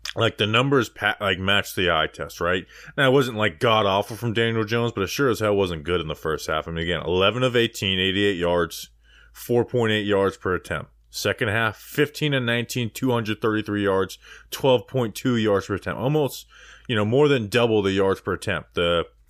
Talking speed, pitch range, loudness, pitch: 200 wpm, 95-120 Hz, -22 LUFS, 110 Hz